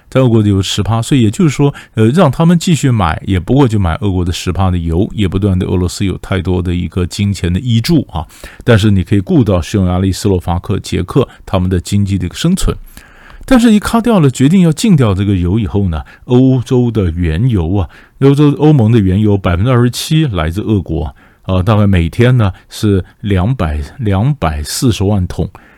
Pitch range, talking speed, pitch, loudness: 90-125 Hz, 305 characters per minute, 100 Hz, -12 LUFS